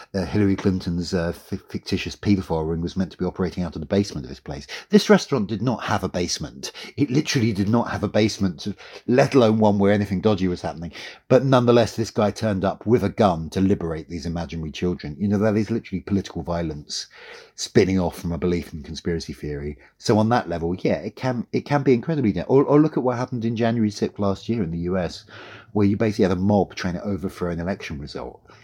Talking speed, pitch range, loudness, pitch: 225 wpm, 85-110 Hz, -22 LUFS, 100 Hz